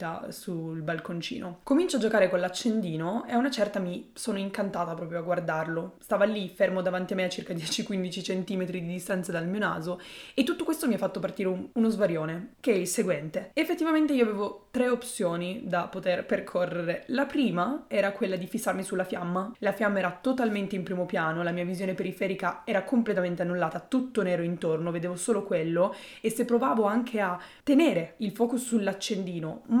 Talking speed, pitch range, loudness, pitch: 185 wpm, 180-230 Hz, -29 LUFS, 195 Hz